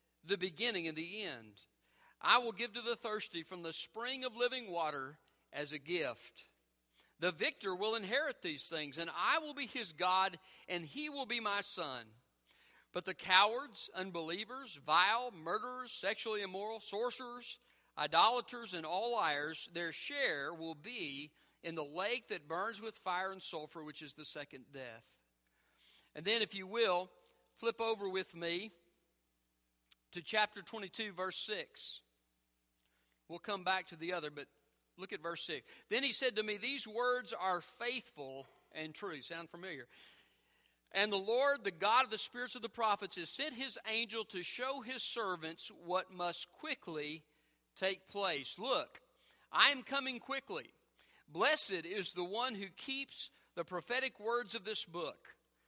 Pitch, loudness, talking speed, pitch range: 190 Hz, -37 LUFS, 160 wpm, 165-235 Hz